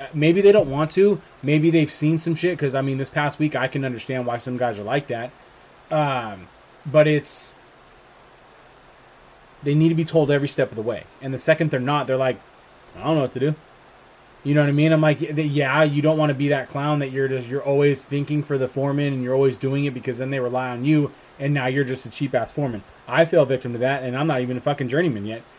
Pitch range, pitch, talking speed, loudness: 130-155 Hz, 140 Hz, 250 wpm, -21 LUFS